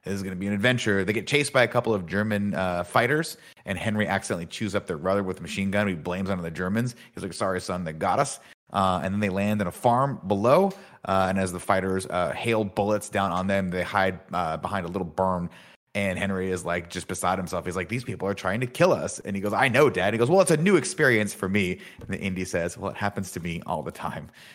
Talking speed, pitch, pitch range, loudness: 270 wpm, 100 Hz, 95-105 Hz, -26 LUFS